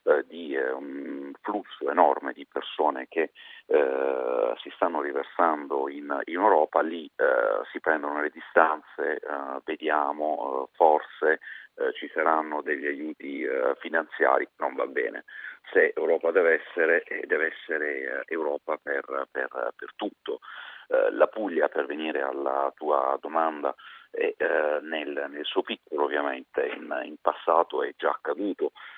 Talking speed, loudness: 135 wpm, -27 LUFS